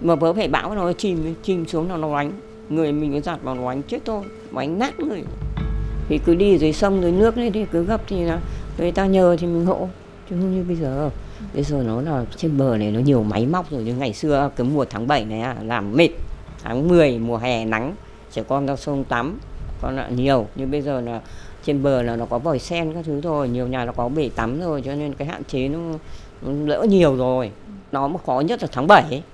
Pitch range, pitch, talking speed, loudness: 125-170 Hz, 145 Hz, 250 wpm, -21 LUFS